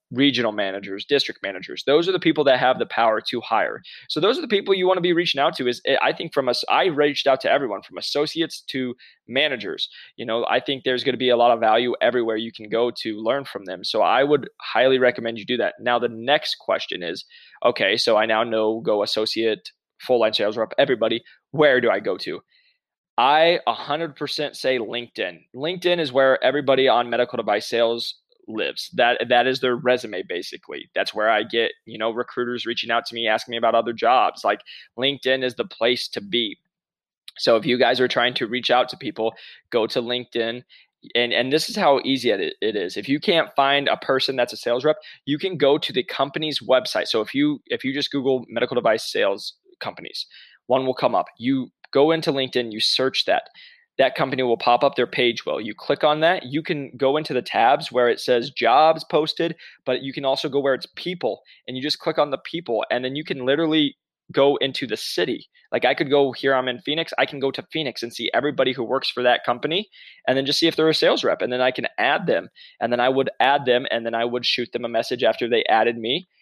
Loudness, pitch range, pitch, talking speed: -21 LUFS, 120-155 Hz, 130 Hz, 230 wpm